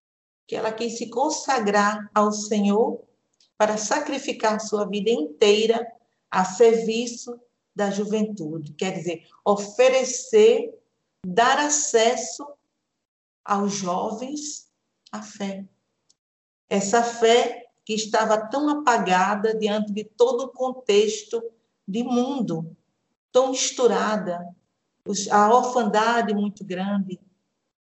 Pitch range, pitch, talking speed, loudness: 205-245 Hz, 225 Hz, 95 wpm, -22 LUFS